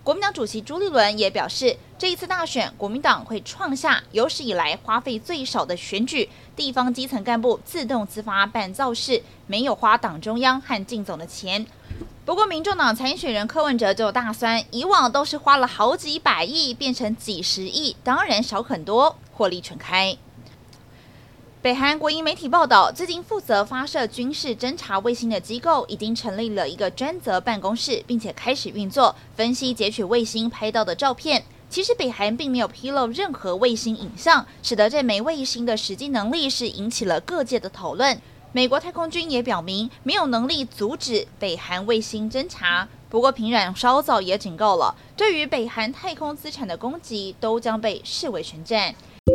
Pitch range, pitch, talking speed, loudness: 210-280 Hz, 235 Hz, 280 characters per minute, -22 LUFS